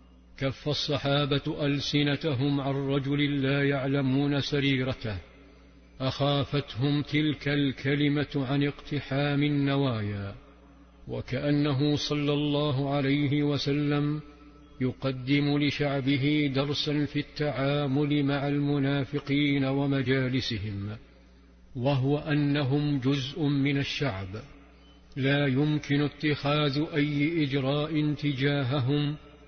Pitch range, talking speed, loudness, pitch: 135-145 Hz, 75 wpm, -28 LUFS, 145 Hz